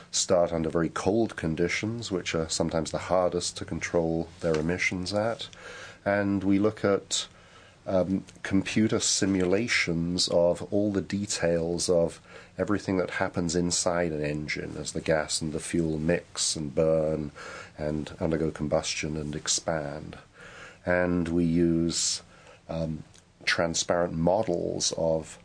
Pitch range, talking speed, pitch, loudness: 80-95 Hz, 125 wpm, 85 Hz, -27 LUFS